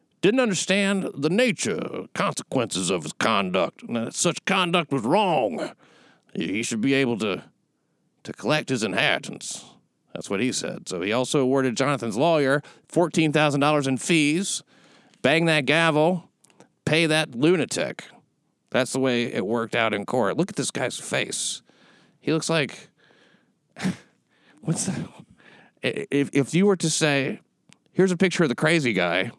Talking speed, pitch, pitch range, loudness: 145 wpm, 150 Hz, 130-170 Hz, -23 LUFS